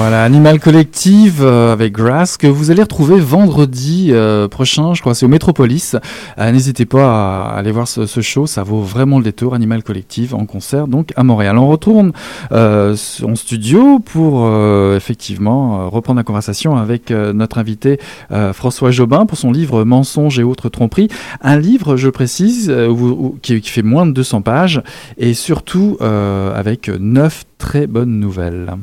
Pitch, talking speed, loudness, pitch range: 125 Hz, 180 wpm, -12 LUFS, 110-145 Hz